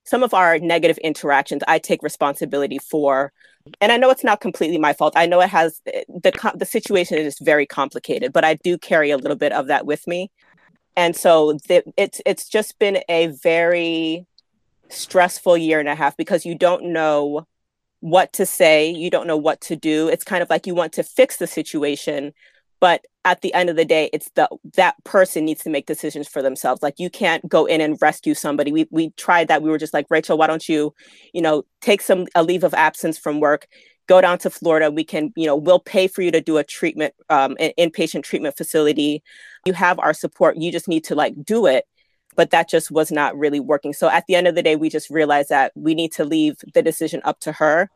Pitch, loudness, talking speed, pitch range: 165 Hz, -18 LUFS, 225 wpm, 155-180 Hz